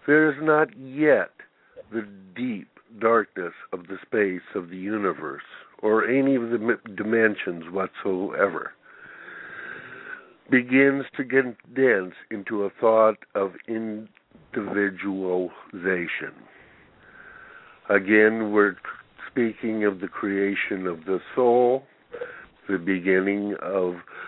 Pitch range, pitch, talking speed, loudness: 100-130 Hz, 110 Hz, 100 wpm, -24 LUFS